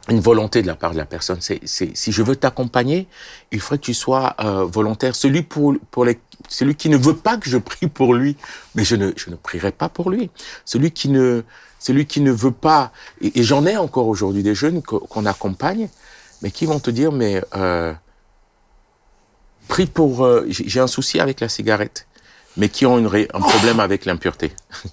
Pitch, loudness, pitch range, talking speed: 125 Hz, -18 LUFS, 105-145 Hz, 205 wpm